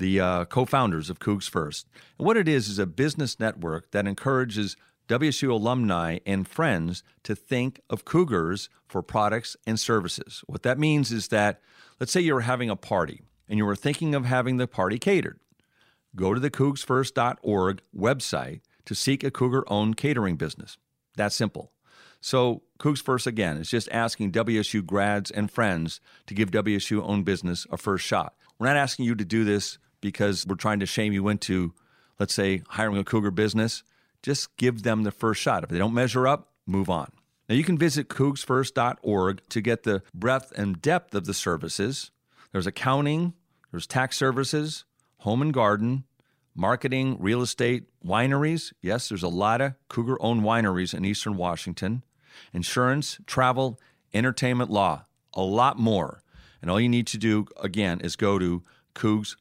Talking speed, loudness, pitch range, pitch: 170 wpm, -26 LUFS, 100-130 Hz, 110 Hz